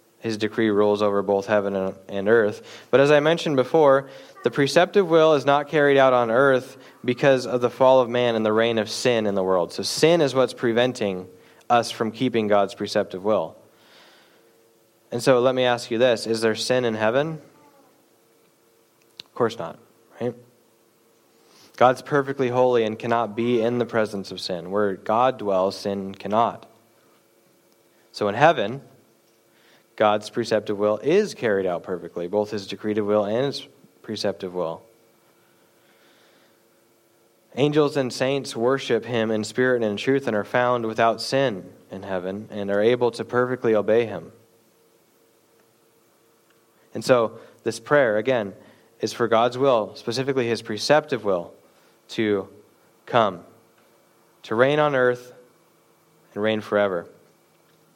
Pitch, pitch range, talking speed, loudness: 115 Hz, 105-130 Hz, 150 wpm, -22 LUFS